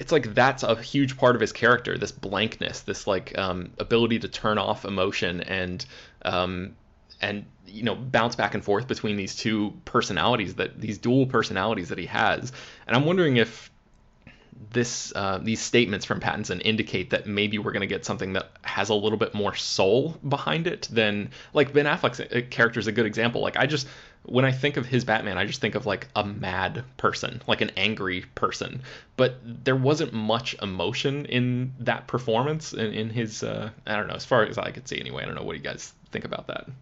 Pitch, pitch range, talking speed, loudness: 110 Hz, 105-125 Hz, 205 wpm, -26 LUFS